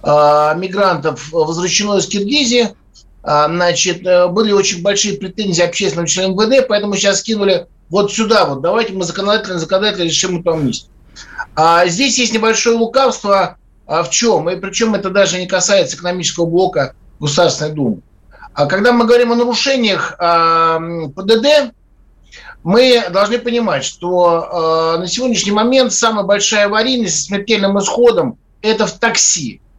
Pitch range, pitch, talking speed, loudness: 170-225 Hz, 195 Hz, 135 wpm, -13 LUFS